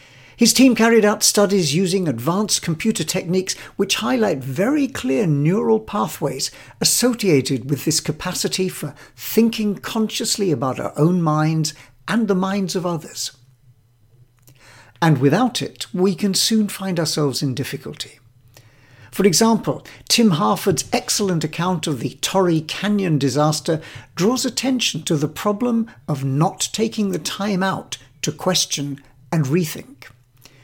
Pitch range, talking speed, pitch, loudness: 140-205 Hz, 130 wpm, 170 Hz, -19 LUFS